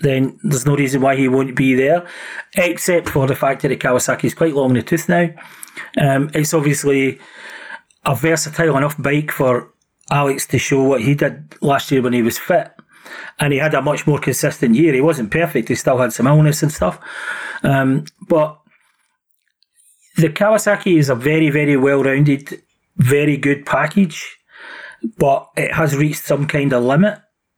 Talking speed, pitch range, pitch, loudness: 180 wpm, 135-160 Hz, 145 Hz, -16 LUFS